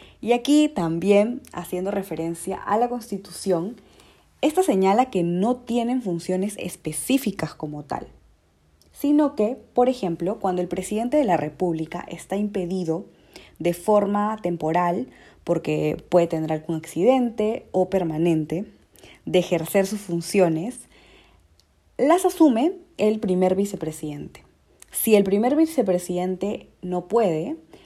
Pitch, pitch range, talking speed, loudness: 190 Hz, 170-230 Hz, 115 wpm, -23 LUFS